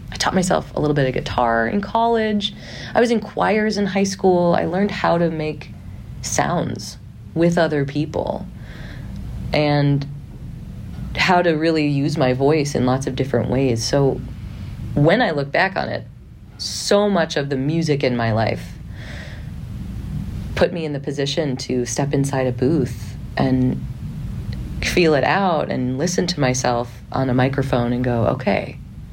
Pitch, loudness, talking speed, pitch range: 140 Hz, -20 LUFS, 160 wpm, 120-165 Hz